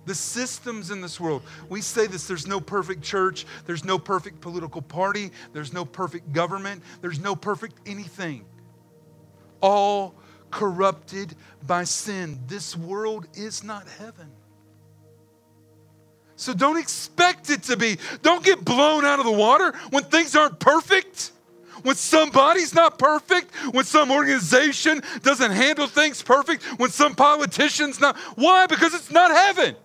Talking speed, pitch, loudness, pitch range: 145 wpm, 210 Hz, -20 LUFS, 175-290 Hz